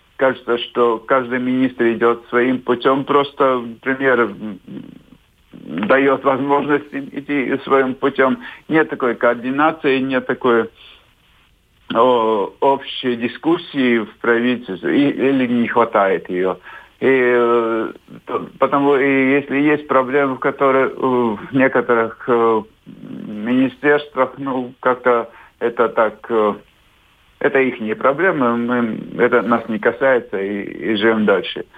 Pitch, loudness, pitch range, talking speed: 130 Hz, -17 LUFS, 120-140 Hz, 110 wpm